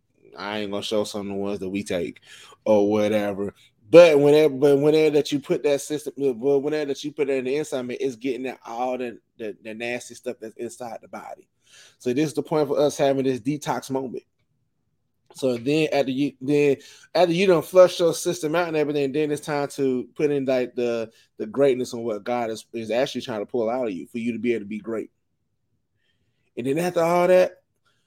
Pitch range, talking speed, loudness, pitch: 120-150 Hz, 225 wpm, -22 LUFS, 135 Hz